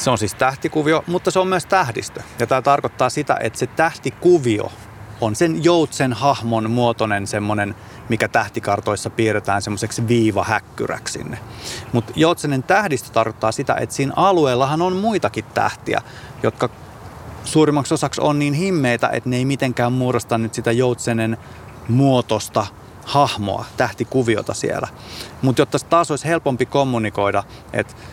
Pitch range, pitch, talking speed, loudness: 110-140 Hz, 120 Hz, 135 wpm, -19 LUFS